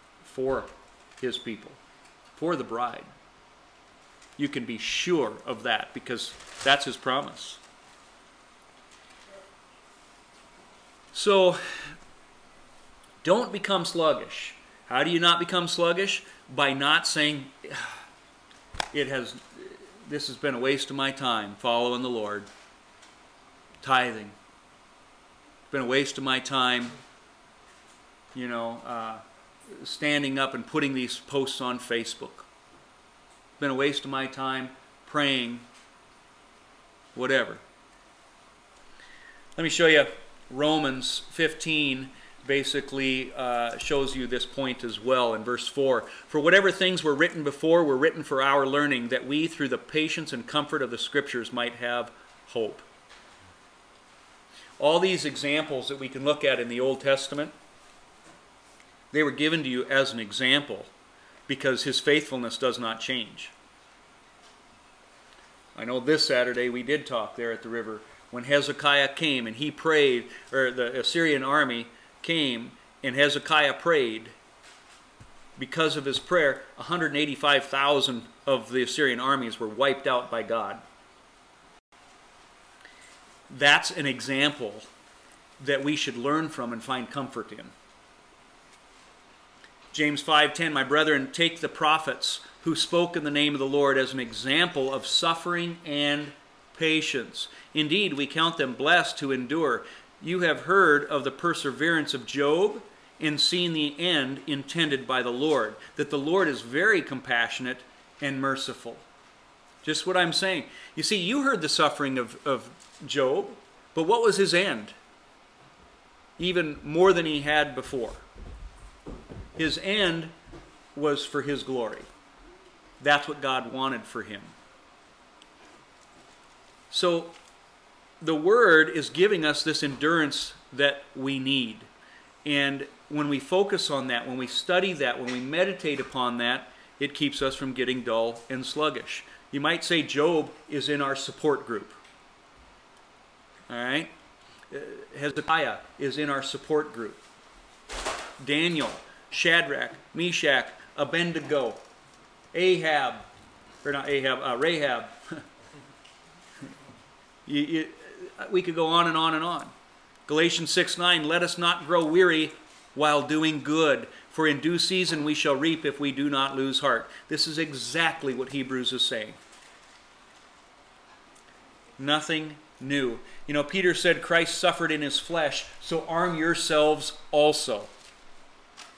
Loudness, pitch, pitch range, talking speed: -26 LUFS, 145 Hz, 130-160 Hz, 130 wpm